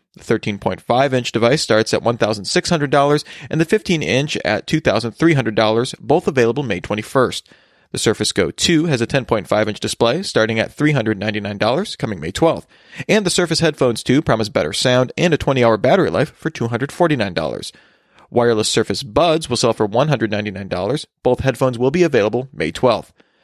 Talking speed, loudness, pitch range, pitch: 160 wpm, -17 LUFS, 110-150 Hz, 125 Hz